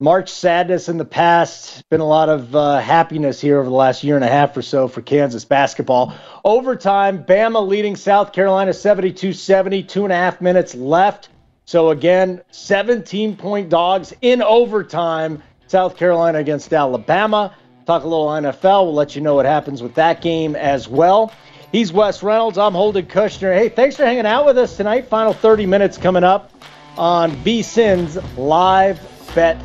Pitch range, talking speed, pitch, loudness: 150-200 Hz, 170 wpm, 180 Hz, -15 LUFS